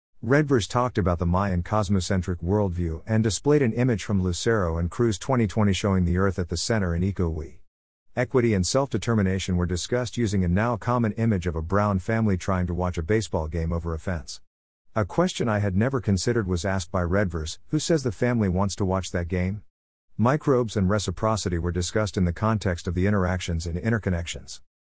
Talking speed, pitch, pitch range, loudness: 190 wpm, 95 Hz, 90-115 Hz, -25 LUFS